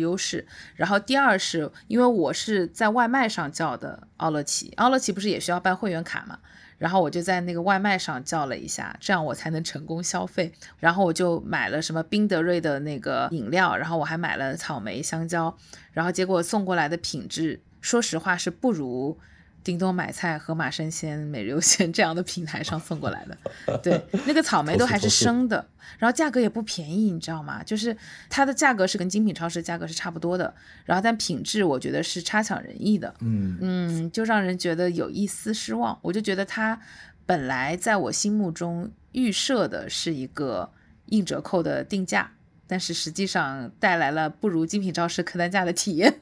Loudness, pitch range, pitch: -25 LUFS, 165-210 Hz, 180 Hz